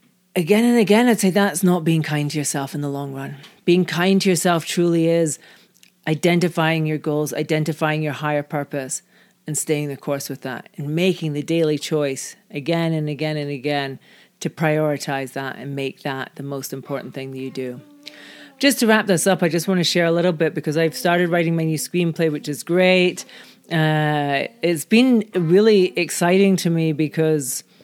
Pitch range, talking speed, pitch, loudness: 145-180 Hz, 190 wpm, 160 Hz, -20 LUFS